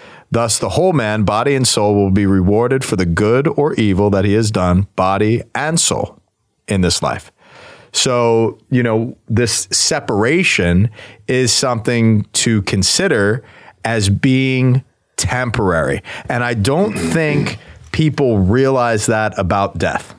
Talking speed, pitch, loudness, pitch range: 135 wpm, 110 Hz, -15 LUFS, 100-130 Hz